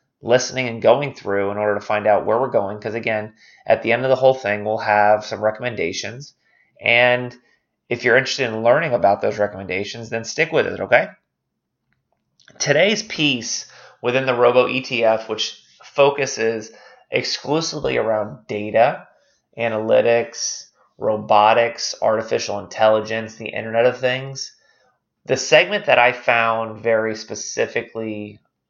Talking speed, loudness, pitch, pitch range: 135 wpm, -19 LUFS, 115 Hz, 110-125 Hz